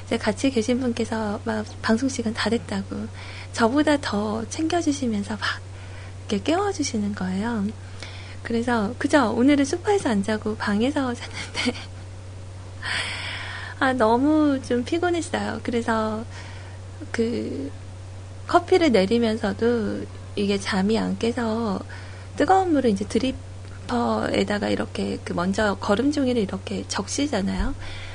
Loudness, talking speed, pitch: -24 LUFS, 250 characters per minute, 200 Hz